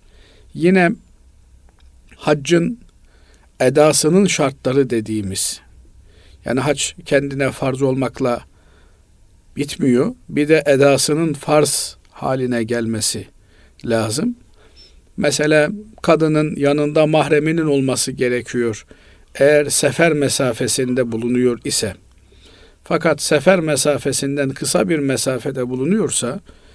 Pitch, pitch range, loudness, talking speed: 130 Hz, 105-150 Hz, -17 LUFS, 80 wpm